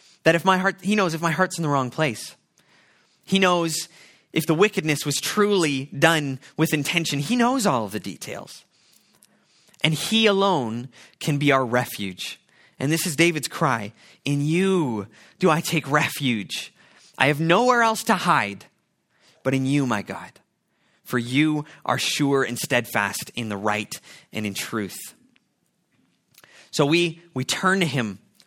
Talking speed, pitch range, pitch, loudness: 160 wpm, 130-175 Hz, 150 Hz, -22 LUFS